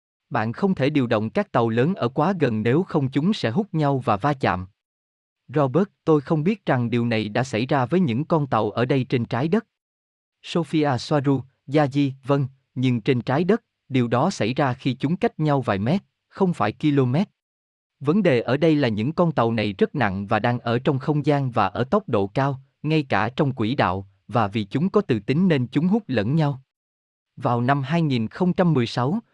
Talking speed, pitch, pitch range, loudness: 205 wpm, 135 Hz, 115-155 Hz, -22 LUFS